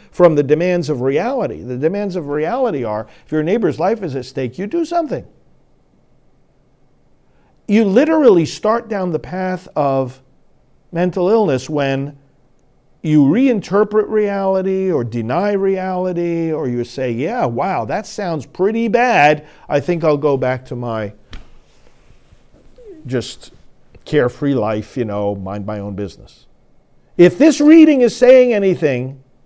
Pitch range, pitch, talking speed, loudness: 130-200 Hz, 160 Hz, 135 wpm, -16 LUFS